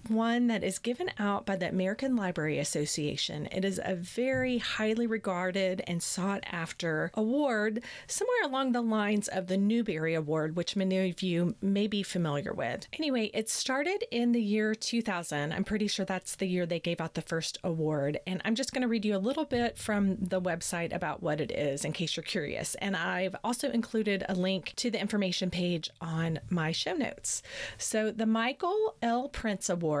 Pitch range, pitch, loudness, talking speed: 175-230 Hz, 195 Hz, -31 LUFS, 190 wpm